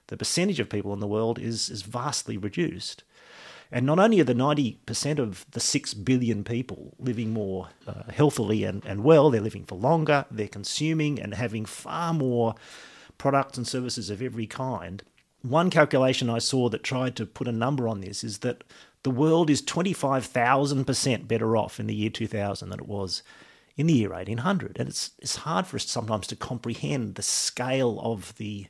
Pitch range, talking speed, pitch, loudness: 105-135 Hz, 185 wpm, 120 Hz, -26 LUFS